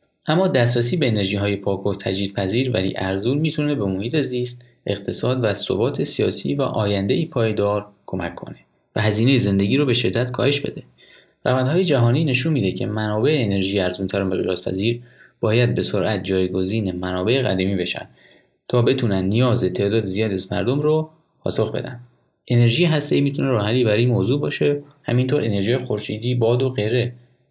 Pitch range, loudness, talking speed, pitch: 100-130 Hz, -20 LUFS, 155 wpm, 120 Hz